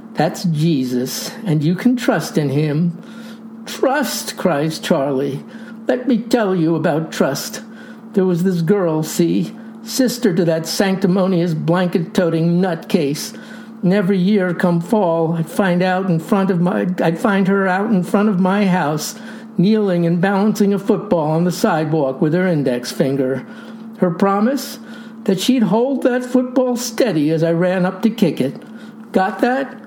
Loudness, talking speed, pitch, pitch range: -17 LUFS, 155 wpm, 195 Hz, 170-225 Hz